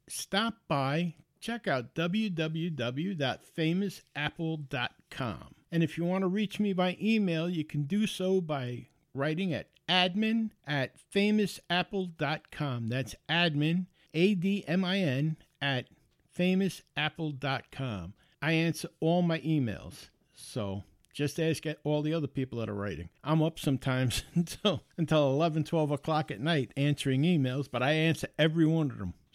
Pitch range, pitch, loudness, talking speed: 140-175 Hz, 155 Hz, -31 LUFS, 130 wpm